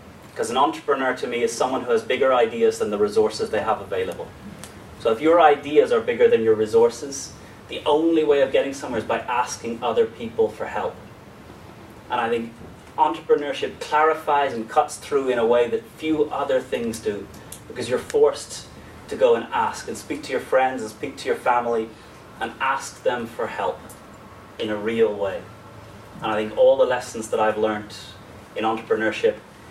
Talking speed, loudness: 185 wpm, -22 LUFS